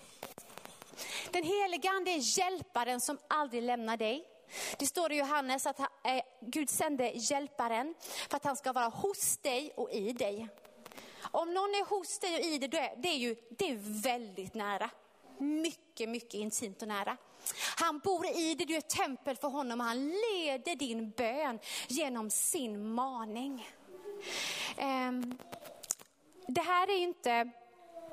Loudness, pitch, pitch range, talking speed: -35 LUFS, 275 Hz, 235-335 Hz, 155 wpm